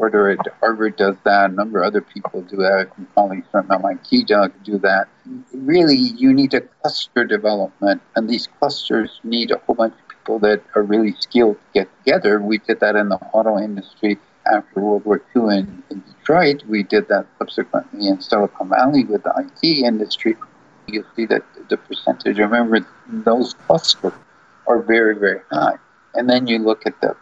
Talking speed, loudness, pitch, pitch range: 180 wpm, -18 LUFS, 110 Hz, 100-140 Hz